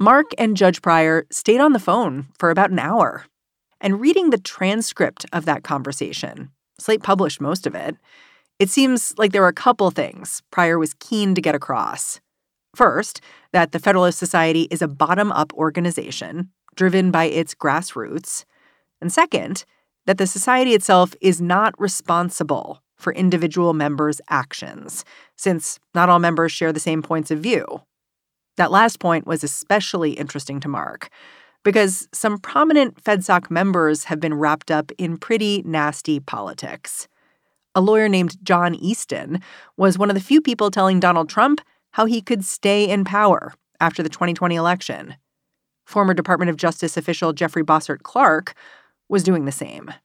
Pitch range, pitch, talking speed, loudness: 165-205 Hz, 180 Hz, 160 wpm, -19 LUFS